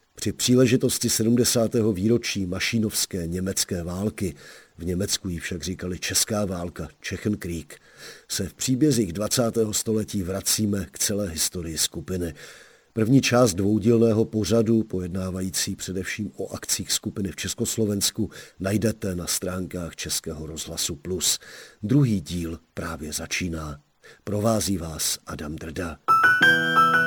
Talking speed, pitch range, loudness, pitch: 110 wpm, 85-110 Hz, -24 LUFS, 100 Hz